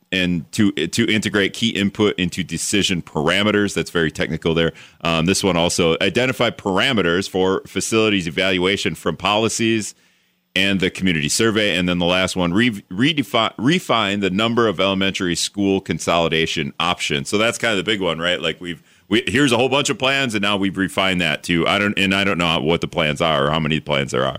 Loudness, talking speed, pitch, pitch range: -18 LUFS, 205 wpm, 95 Hz, 85-105 Hz